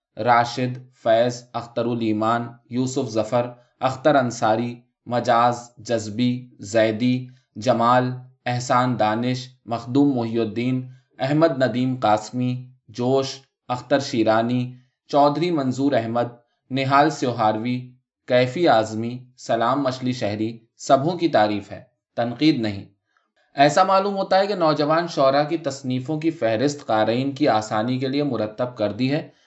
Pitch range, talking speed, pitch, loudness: 115-135 Hz, 120 wpm, 125 Hz, -22 LUFS